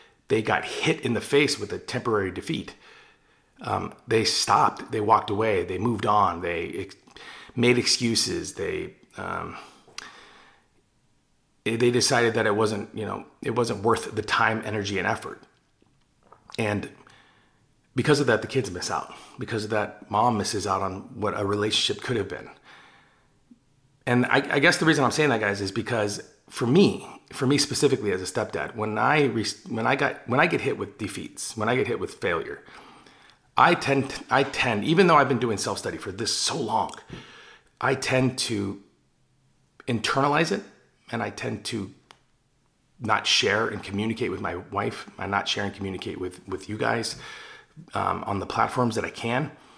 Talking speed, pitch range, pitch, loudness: 175 wpm, 105-135 Hz, 120 Hz, -25 LUFS